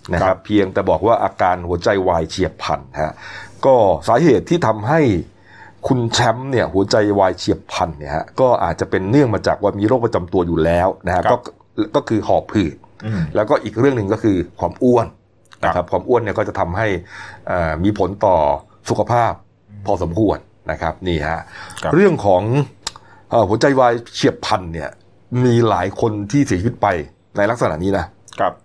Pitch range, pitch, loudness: 90-115 Hz, 100 Hz, -17 LUFS